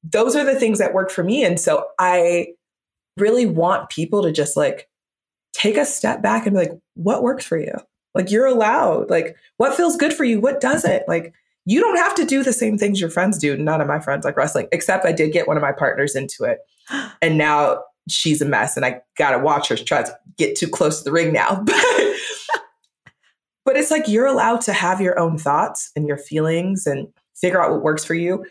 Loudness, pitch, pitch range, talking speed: -19 LUFS, 190 Hz, 165-260 Hz, 225 wpm